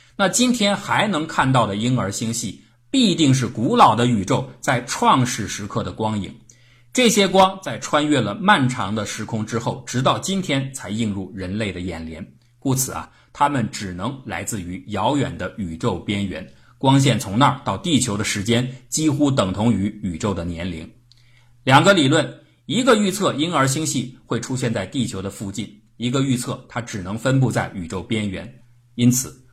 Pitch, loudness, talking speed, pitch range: 120 Hz, -20 LUFS, 260 characters per minute, 105-135 Hz